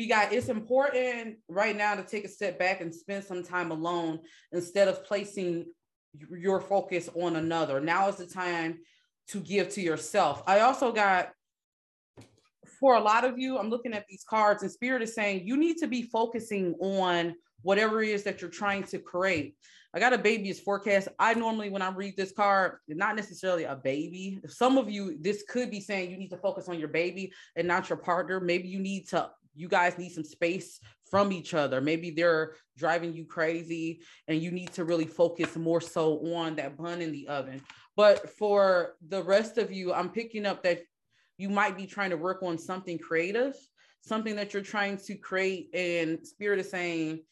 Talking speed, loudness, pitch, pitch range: 200 wpm, -29 LUFS, 185 Hz, 170-205 Hz